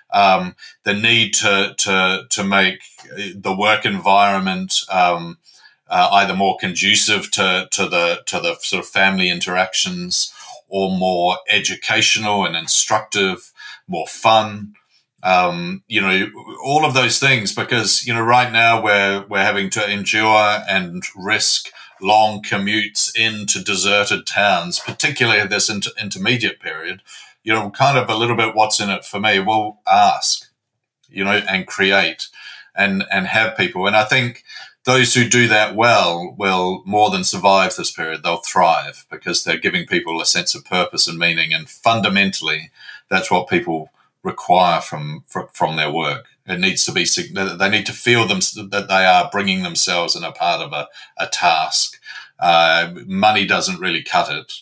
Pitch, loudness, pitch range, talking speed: 105 Hz, -16 LUFS, 95-120 Hz, 160 wpm